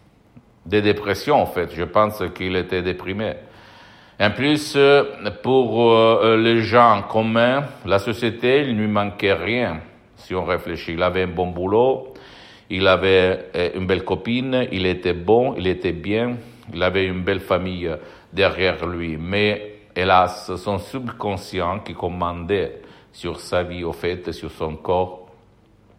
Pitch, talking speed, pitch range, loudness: 100 Hz, 145 wpm, 90-110 Hz, -20 LUFS